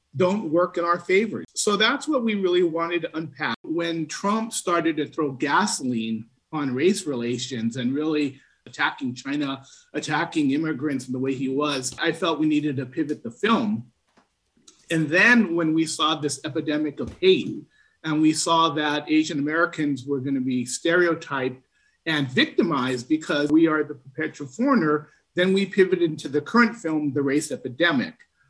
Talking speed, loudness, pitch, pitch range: 165 wpm, -23 LUFS, 155 Hz, 140-175 Hz